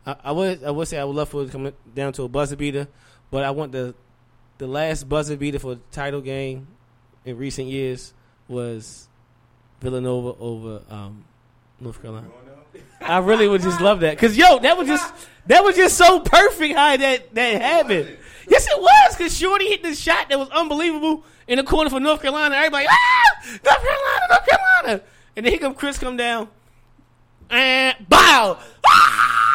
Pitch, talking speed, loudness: 150 Hz, 185 wpm, -16 LUFS